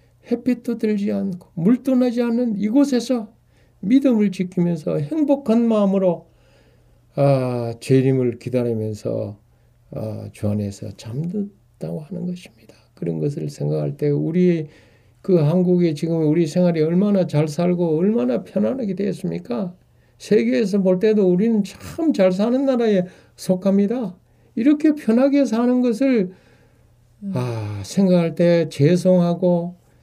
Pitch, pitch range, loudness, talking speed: 180 Hz, 135-220 Hz, -20 LUFS, 270 characters per minute